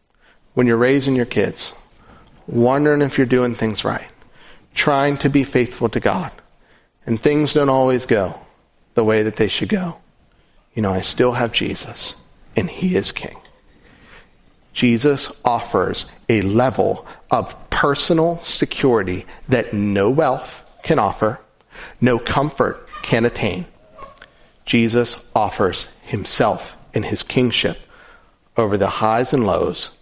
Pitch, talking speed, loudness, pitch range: 125 Hz, 130 wpm, -19 LUFS, 115-140 Hz